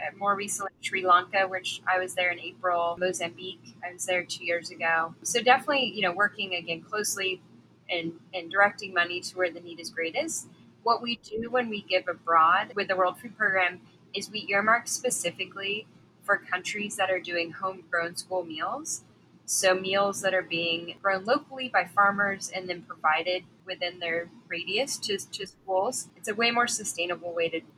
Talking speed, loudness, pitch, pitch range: 180 wpm, -27 LUFS, 185 Hz, 175-205 Hz